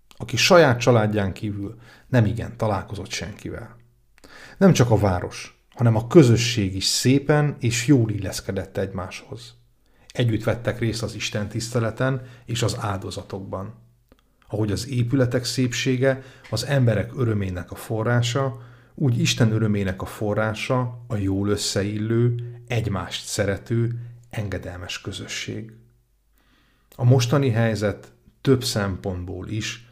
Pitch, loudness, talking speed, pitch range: 115 Hz, -22 LUFS, 115 wpm, 105-125 Hz